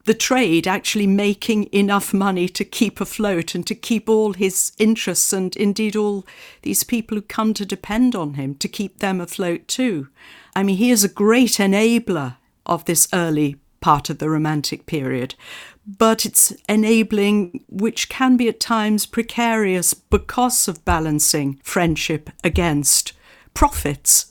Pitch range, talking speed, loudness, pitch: 170-220 Hz, 150 wpm, -18 LUFS, 200 Hz